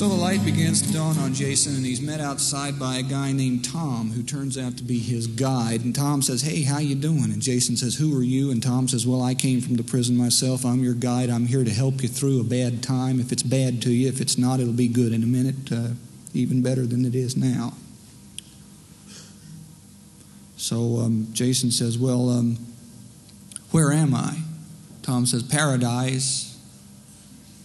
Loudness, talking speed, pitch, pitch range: -23 LUFS, 200 wpm, 125 Hz, 120-135 Hz